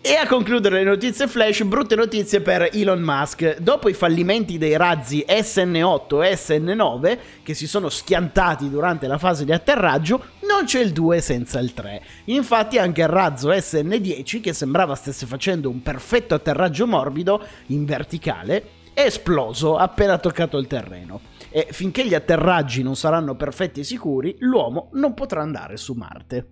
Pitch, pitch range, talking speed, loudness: 170 Hz, 145-205 Hz, 160 wpm, -20 LUFS